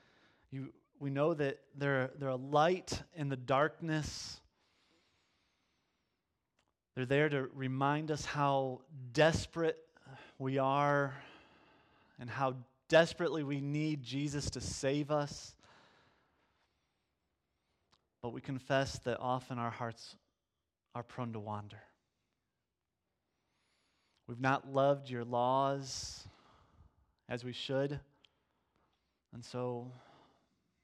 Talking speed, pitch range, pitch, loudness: 95 wpm, 120-145 Hz, 135 Hz, -36 LUFS